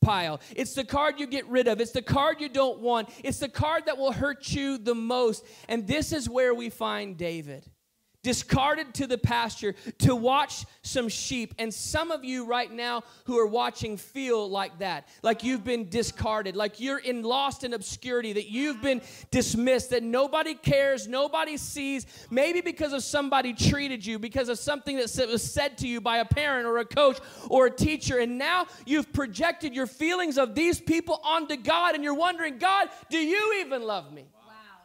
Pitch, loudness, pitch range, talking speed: 260 Hz, -27 LUFS, 235-290 Hz, 195 wpm